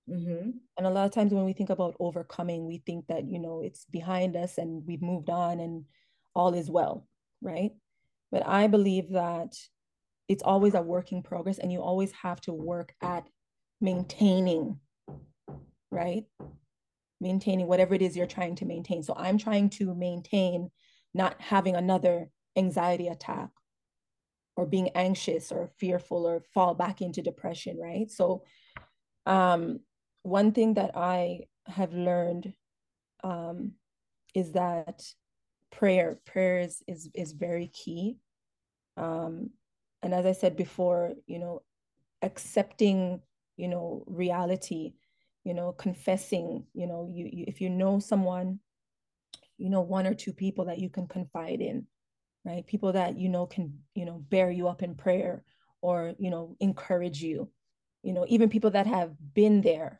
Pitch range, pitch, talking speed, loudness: 175-190 Hz, 180 Hz, 150 wpm, -30 LUFS